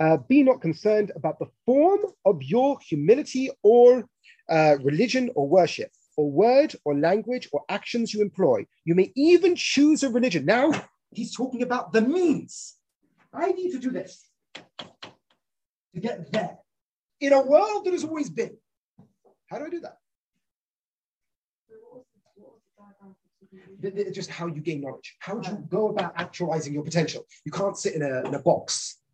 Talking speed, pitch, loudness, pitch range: 155 wpm, 210 Hz, -23 LUFS, 170-275 Hz